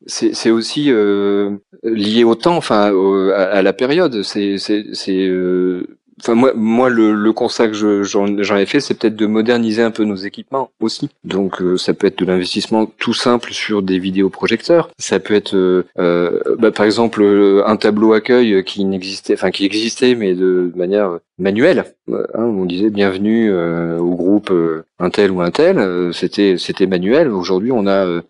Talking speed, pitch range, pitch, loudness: 195 wpm, 95-115 Hz, 100 Hz, -15 LUFS